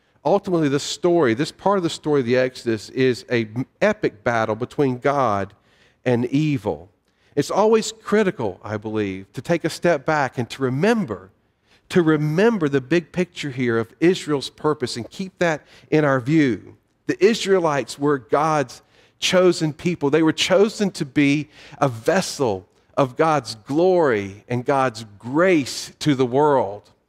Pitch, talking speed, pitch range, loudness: 145 Hz, 155 wpm, 120-170 Hz, -21 LUFS